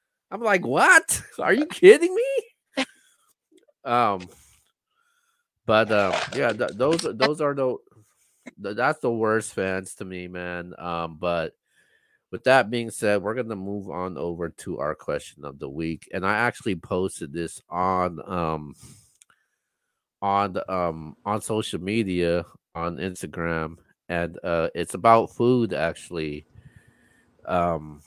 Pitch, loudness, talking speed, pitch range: 95 Hz, -24 LUFS, 135 wpm, 85-115 Hz